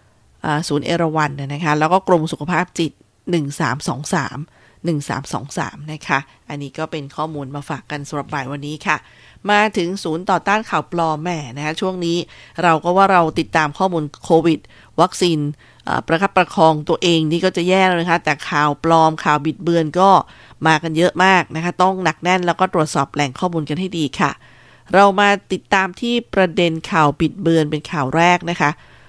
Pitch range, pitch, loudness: 150-180 Hz, 160 Hz, -18 LUFS